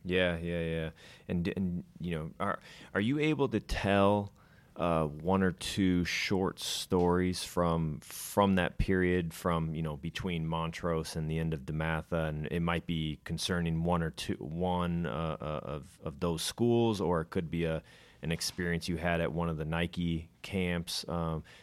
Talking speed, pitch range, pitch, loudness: 180 wpm, 80-90 Hz, 85 Hz, -33 LUFS